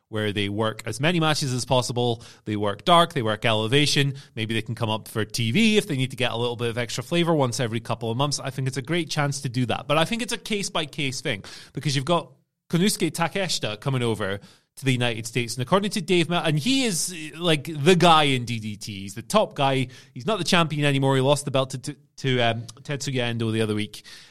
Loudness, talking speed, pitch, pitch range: -24 LUFS, 240 wpm, 135 Hz, 115-160 Hz